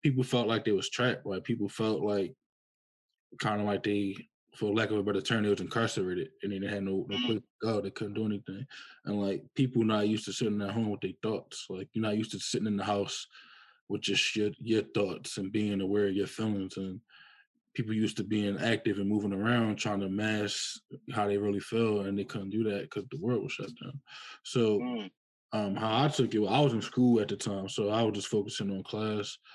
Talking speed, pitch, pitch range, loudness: 235 wpm, 105 Hz, 100-115 Hz, -32 LUFS